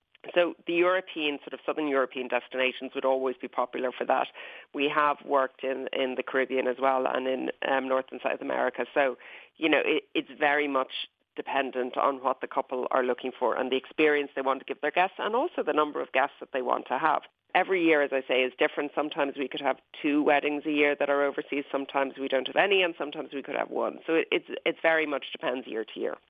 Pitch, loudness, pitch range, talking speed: 140 Hz, -28 LUFS, 130-150 Hz, 235 wpm